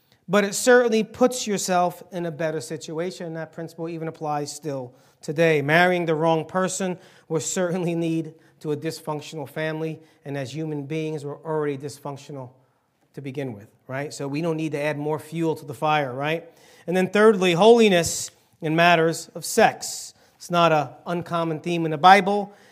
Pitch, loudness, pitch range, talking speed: 160 Hz, -23 LUFS, 150-175 Hz, 170 wpm